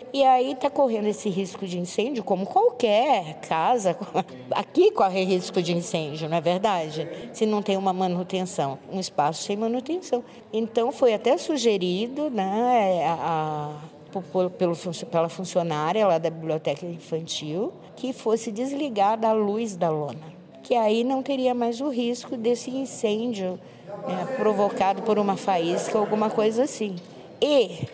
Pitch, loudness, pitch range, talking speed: 205 Hz, -25 LUFS, 175-240 Hz, 150 wpm